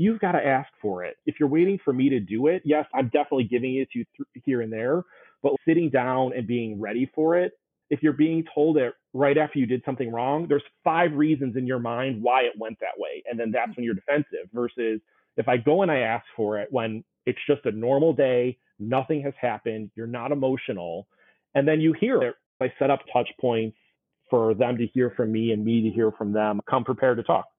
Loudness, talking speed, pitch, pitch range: -25 LUFS, 235 wpm, 130 Hz, 120-150 Hz